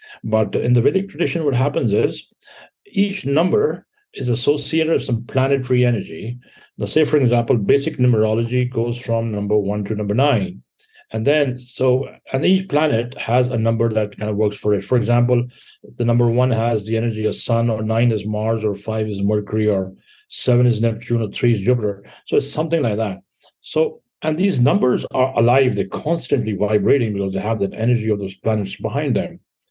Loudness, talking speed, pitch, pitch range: -19 LUFS, 190 wpm, 115 Hz, 110-135 Hz